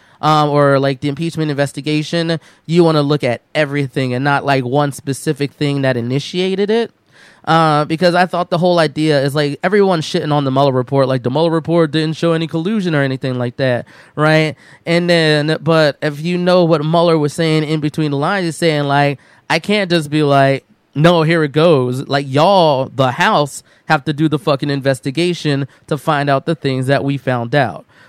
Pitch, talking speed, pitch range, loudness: 150 Hz, 200 wpm, 140-165 Hz, -15 LUFS